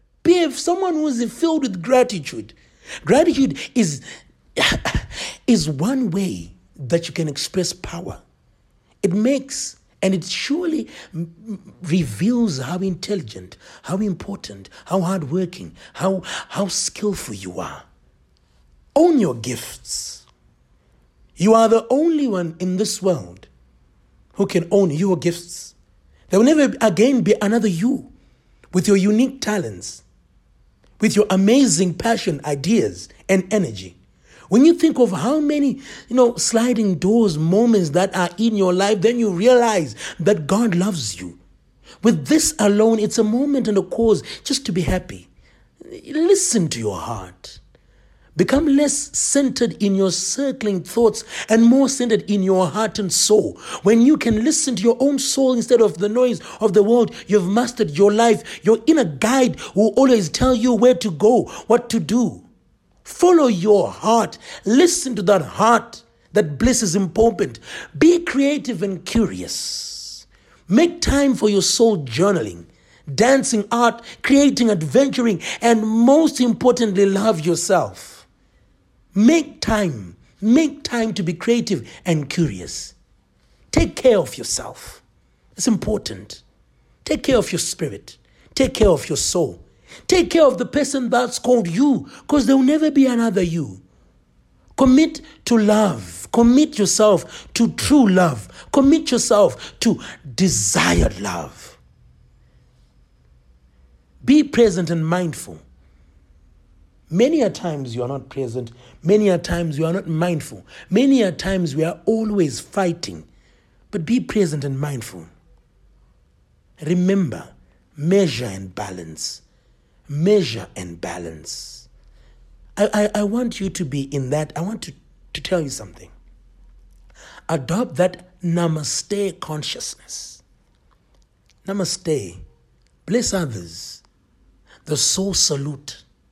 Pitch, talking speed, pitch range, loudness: 200 Hz, 135 wpm, 150-235 Hz, -18 LUFS